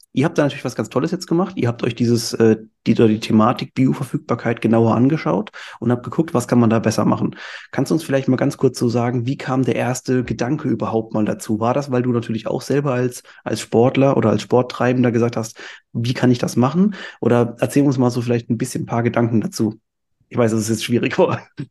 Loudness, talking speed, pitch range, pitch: -19 LUFS, 230 wpm, 115-130 Hz, 120 Hz